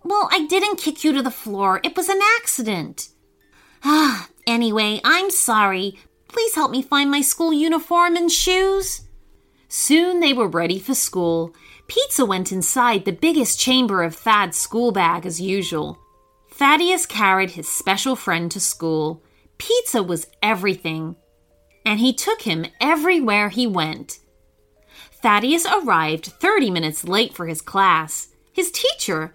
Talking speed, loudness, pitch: 145 wpm, -19 LUFS, 225 Hz